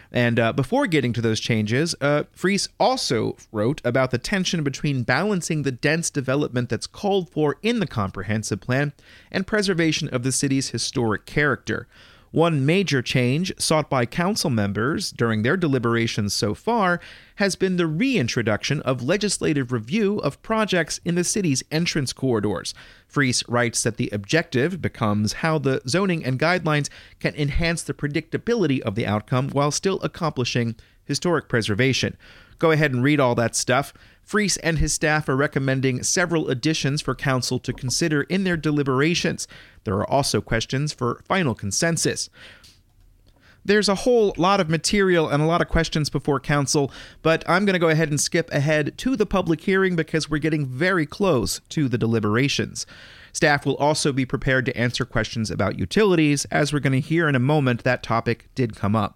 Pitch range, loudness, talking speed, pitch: 120-165 Hz, -22 LUFS, 170 wpm, 140 Hz